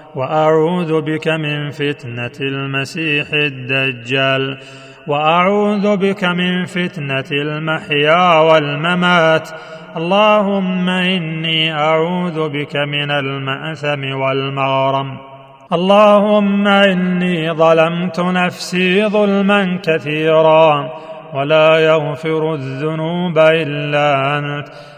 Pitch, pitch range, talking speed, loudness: 160 Hz, 145-180 Hz, 70 wpm, -14 LUFS